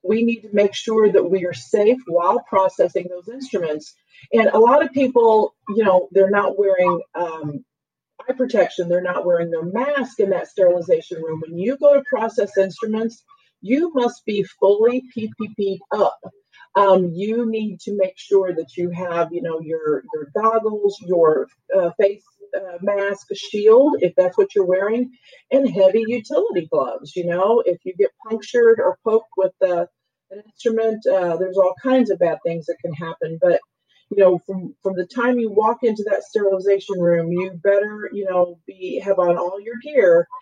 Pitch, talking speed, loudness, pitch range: 200 Hz, 180 wpm, -19 LUFS, 180-235 Hz